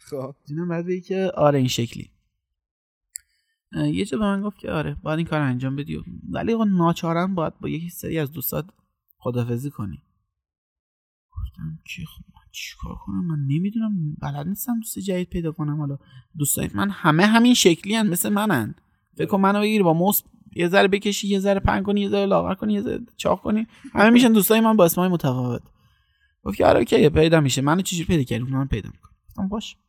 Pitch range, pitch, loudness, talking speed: 135-200 Hz, 165 Hz, -21 LUFS, 195 wpm